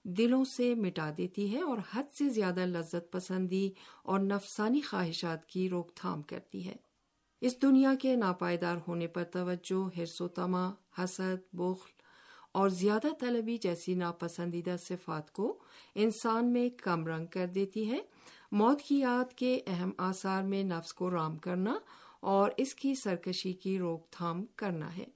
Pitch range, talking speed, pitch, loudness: 180-240 Hz, 150 wpm, 190 Hz, -34 LUFS